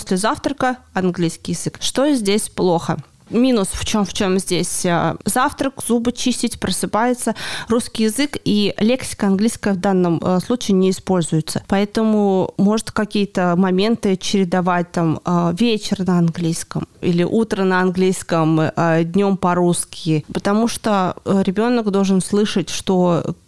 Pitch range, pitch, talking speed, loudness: 175-220 Hz, 195 Hz, 125 wpm, -18 LUFS